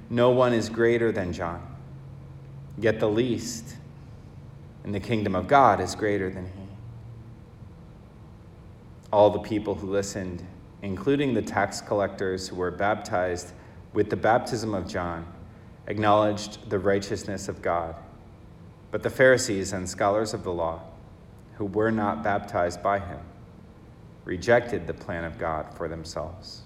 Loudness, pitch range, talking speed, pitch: -26 LUFS, 90-115 Hz, 135 wpm, 100 Hz